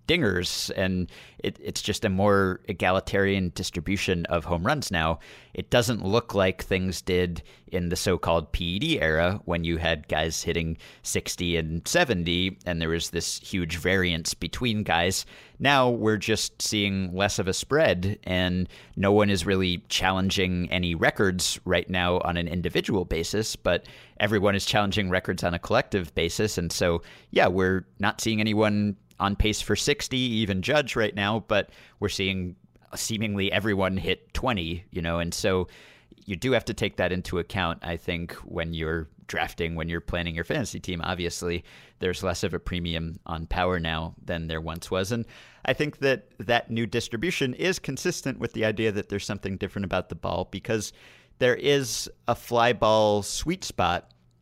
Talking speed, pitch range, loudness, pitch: 175 wpm, 85-105 Hz, -26 LUFS, 95 Hz